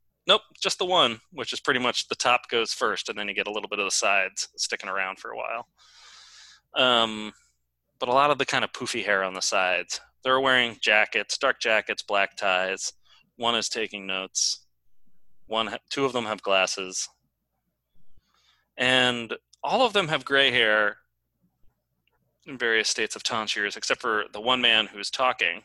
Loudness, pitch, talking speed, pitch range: -24 LUFS, 125 Hz, 180 wpm, 100-145 Hz